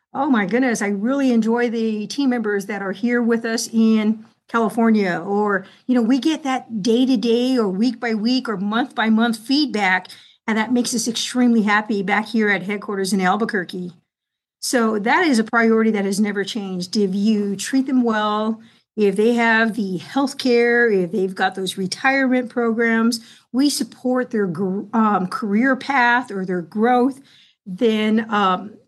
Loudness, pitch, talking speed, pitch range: -19 LUFS, 225 Hz, 170 wpm, 205-245 Hz